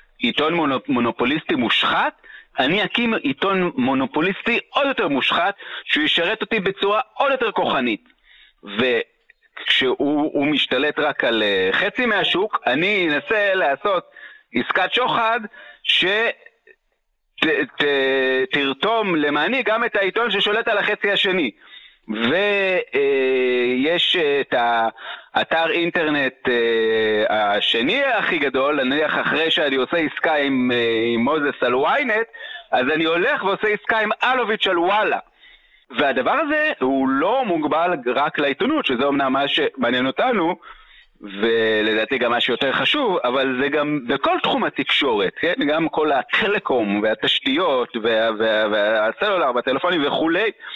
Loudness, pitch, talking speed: -19 LUFS, 165 Hz, 120 wpm